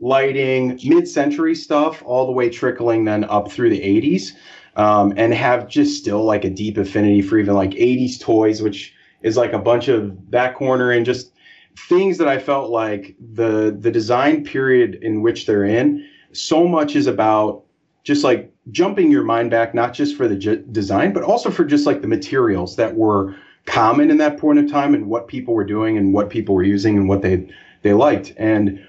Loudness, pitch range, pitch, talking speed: -17 LUFS, 105-160 Hz, 120 Hz, 200 wpm